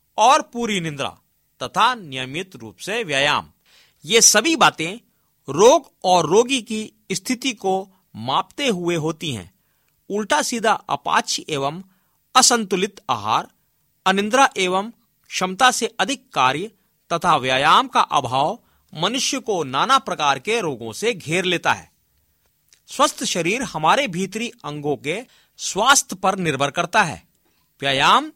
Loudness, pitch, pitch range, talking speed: -19 LUFS, 190 Hz, 155-235 Hz, 125 wpm